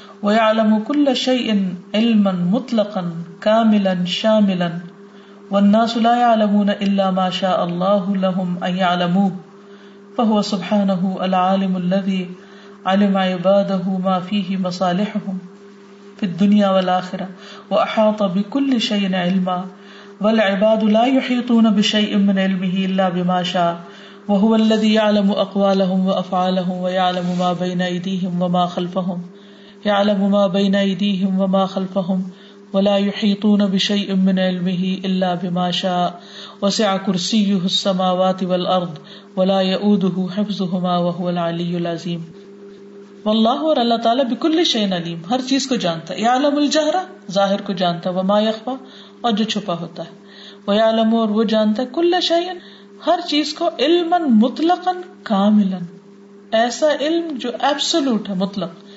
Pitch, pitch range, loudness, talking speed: 200 Hz, 185-215 Hz, -18 LUFS, 130 wpm